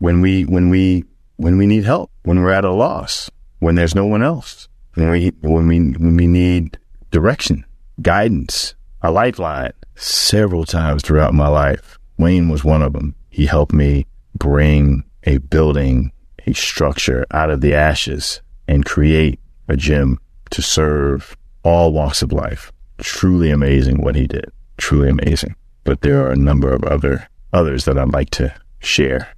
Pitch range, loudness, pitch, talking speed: 70-85 Hz, -16 LUFS, 75 Hz, 165 wpm